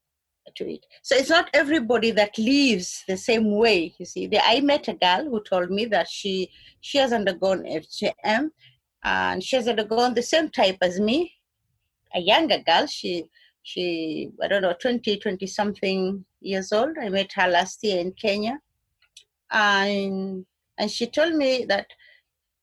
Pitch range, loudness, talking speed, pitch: 185-240 Hz, -23 LUFS, 160 wpm, 205 Hz